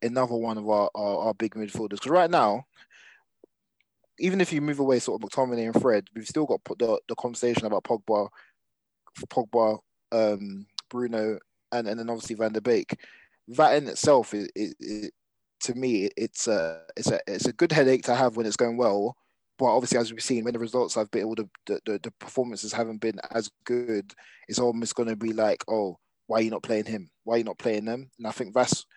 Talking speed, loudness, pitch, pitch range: 215 wpm, -27 LUFS, 115 Hz, 110-125 Hz